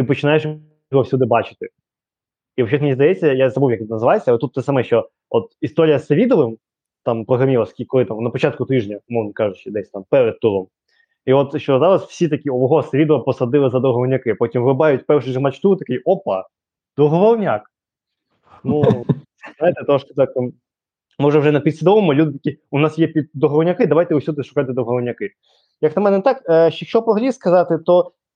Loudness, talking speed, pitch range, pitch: -17 LUFS, 175 wpm, 130-165 Hz, 145 Hz